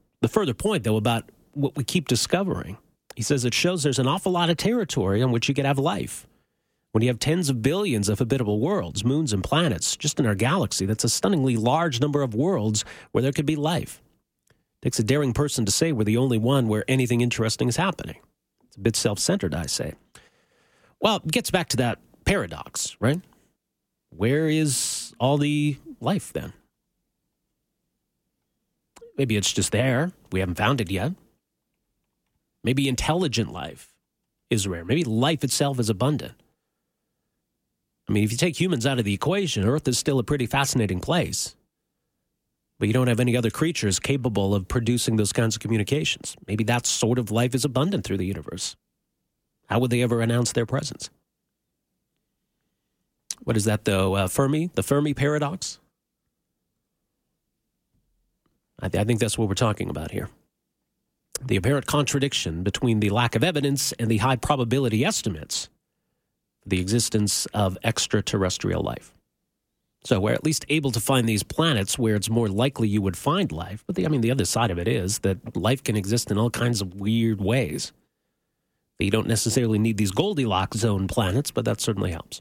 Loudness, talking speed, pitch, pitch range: -24 LUFS, 175 wpm, 120 Hz, 105-140 Hz